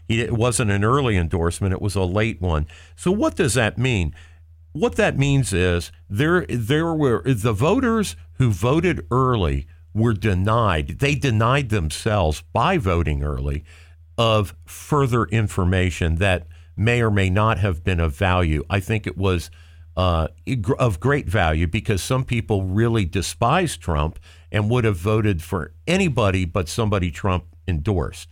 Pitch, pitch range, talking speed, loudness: 100 Hz, 85-120 Hz, 150 wpm, -21 LUFS